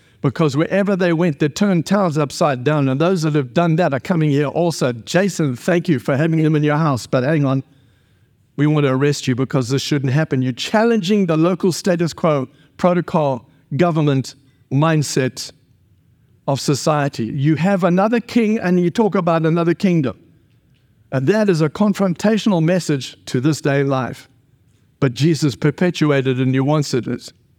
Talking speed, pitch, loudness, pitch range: 170 wpm, 150 Hz, -17 LUFS, 135-175 Hz